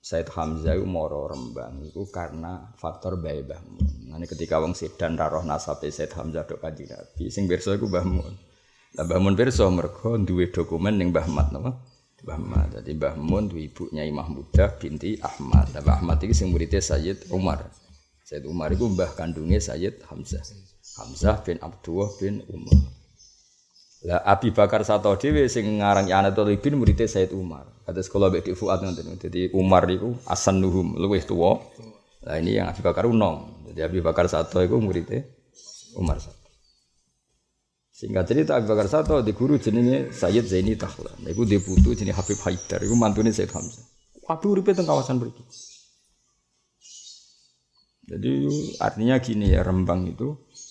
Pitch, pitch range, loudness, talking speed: 95 Hz, 80-105 Hz, -24 LUFS, 160 wpm